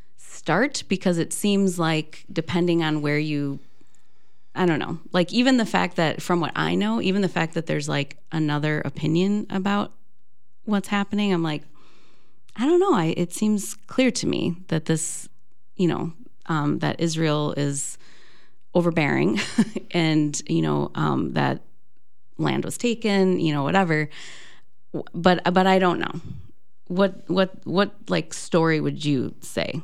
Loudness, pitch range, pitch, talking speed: -23 LUFS, 150-195 Hz, 170 Hz, 155 wpm